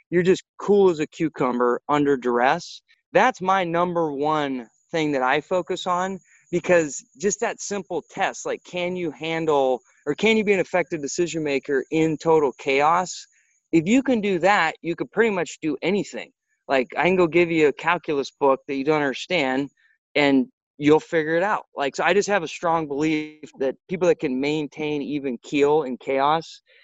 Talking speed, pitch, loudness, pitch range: 185 wpm, 160 Hz, -22 LUFS, 145-185 Hz